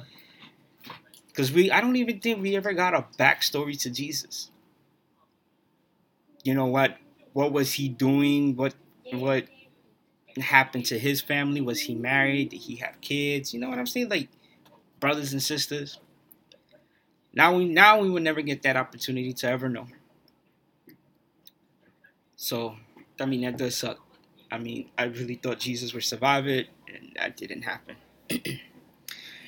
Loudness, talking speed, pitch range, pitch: -25 LUFS, 150 wpm, 125-145 Hz, 135 Hz